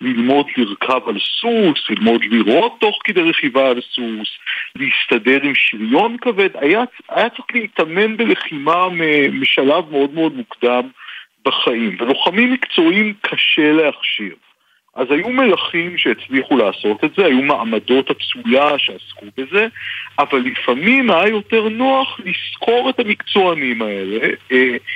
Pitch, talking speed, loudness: 185 Hz, 120 wpm, -15 LUFS